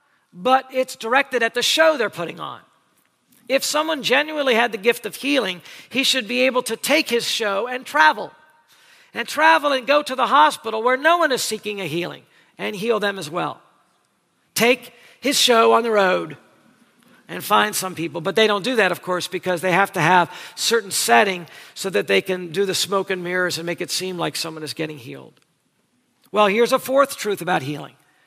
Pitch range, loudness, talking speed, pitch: 180-260 Hz, -19 LUFS, 200 wpm, 225 Hz